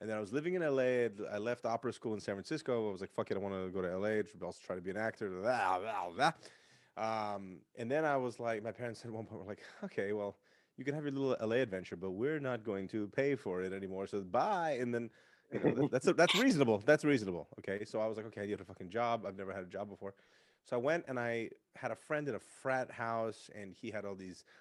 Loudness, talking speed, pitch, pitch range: -37 LUFS, 265 wpm, 110 Hz, 100-125 Hz